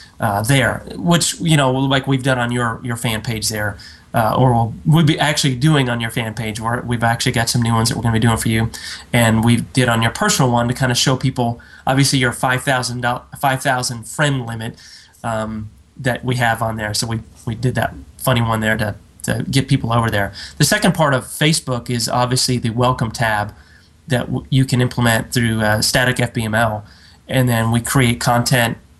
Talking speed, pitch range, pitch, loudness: 210 wpm, 115-130 Hz, 120 Hz, -17 LUFS